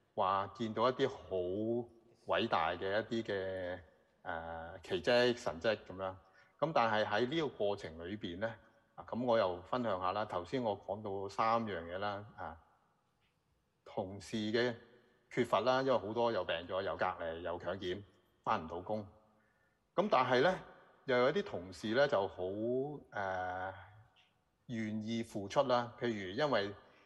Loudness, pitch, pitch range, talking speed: -37 LUFS, 110 Hz, 95-120 Hz, 210 characters per minute